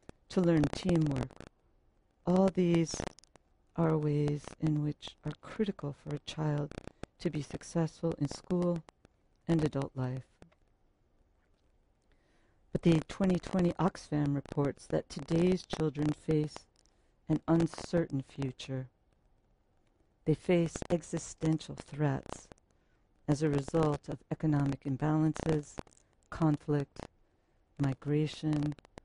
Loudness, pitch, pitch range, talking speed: -33 LUFS, 150 Hz, 135-165 Hz, 95 wpm